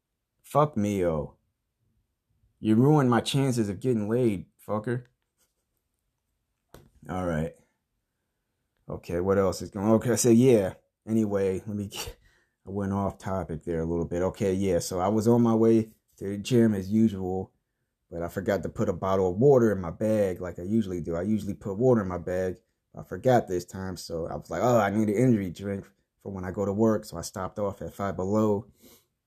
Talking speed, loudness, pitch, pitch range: 200 wpm, -26 LUFS, 100 Hz, 95-110 Hz